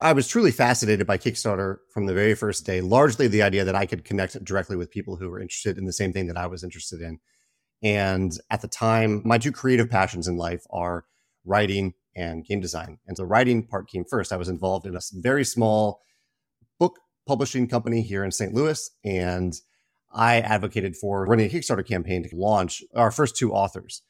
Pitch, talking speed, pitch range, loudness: 100 Hz, 205 wpm, 95-115 Hz, -24 LUFS